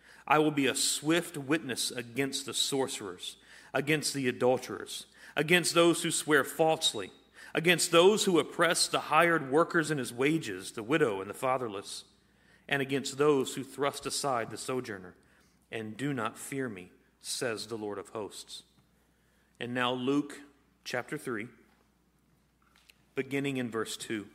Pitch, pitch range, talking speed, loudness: 140 Hz, 125-155 Hz, 145 wpm, -30 LUFS